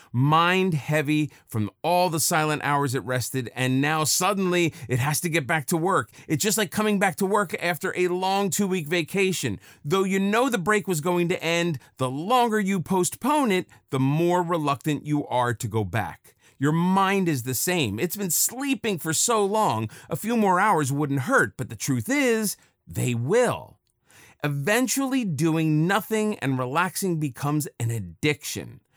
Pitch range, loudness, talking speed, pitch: 140-195 Hz, -24 LUFS, 175 wpm, 170 Hz